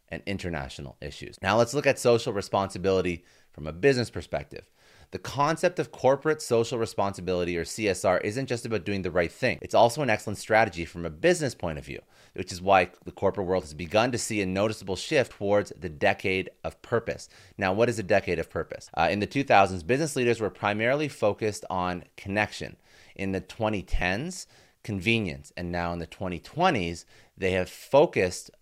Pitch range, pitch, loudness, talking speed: 90-115 Hz, 100 Hz, -27 LUFS, 180 wpm